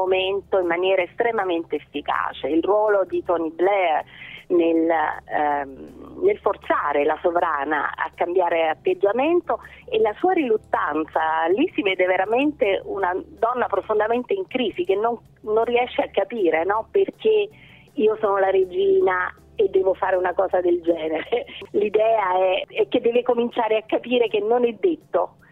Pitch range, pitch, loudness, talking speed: 175-285 Hz, 210 Hz, -22 LUFS, 145 wpm